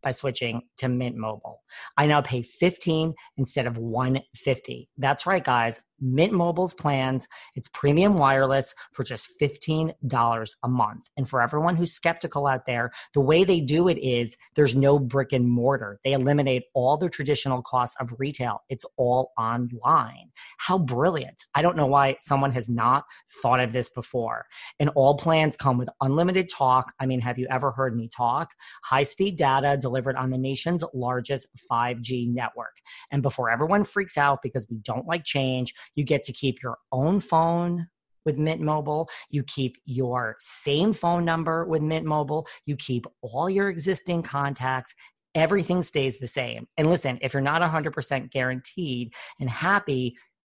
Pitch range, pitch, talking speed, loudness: 125-160 Hz, 135 Hz, 165 wpm, -25 LUFS